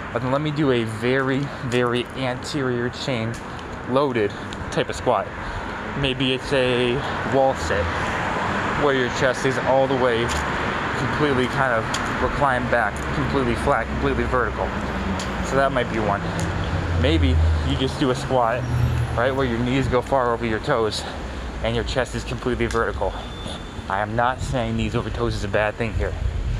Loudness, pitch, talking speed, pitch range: -22 LUFS, 120 Hz, 165 wpm, 105-130 Hz